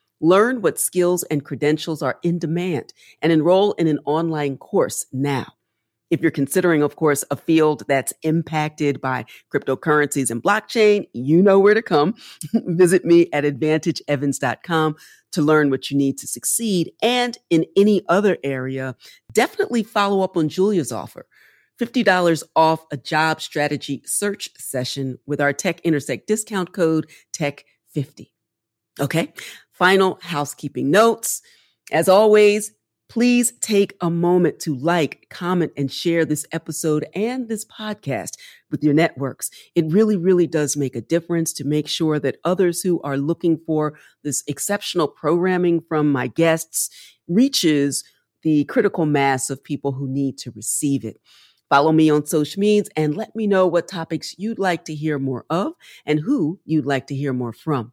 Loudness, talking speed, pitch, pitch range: -20 LUFS, 155 wpm, 160 Hz, 145-185 Hz